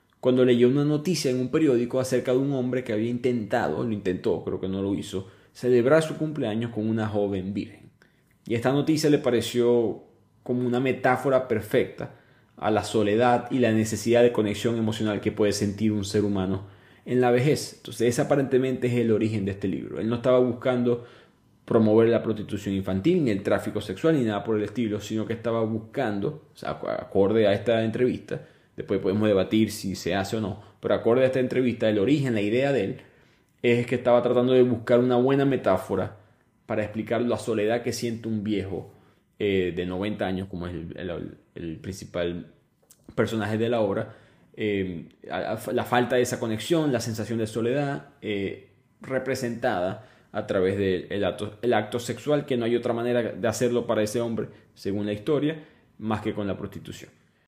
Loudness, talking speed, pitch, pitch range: -25 LUFS, 185 wpm, 115 Hz, 105-125 Hz